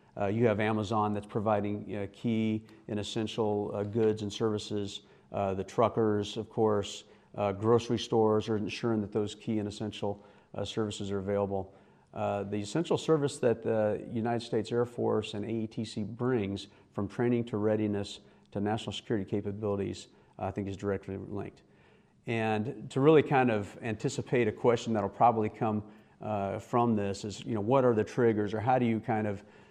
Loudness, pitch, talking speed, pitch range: -31 LUFS, 105 Hz, 180 wpm, 100-115 Hz